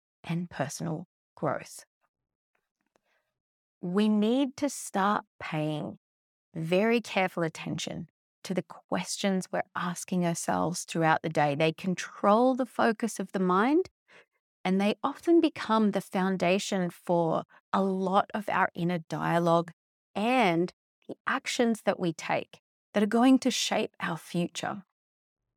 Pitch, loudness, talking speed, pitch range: 190 Hz, -29 LUFS, 125 wpm, 170-220 Hz